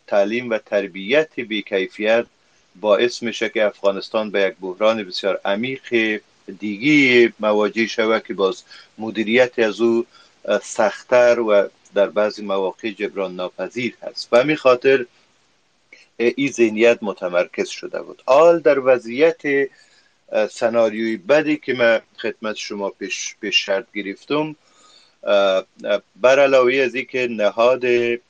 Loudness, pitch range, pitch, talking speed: -19 LUFS, 105-125 Hz, 115 Hz, 120 wpm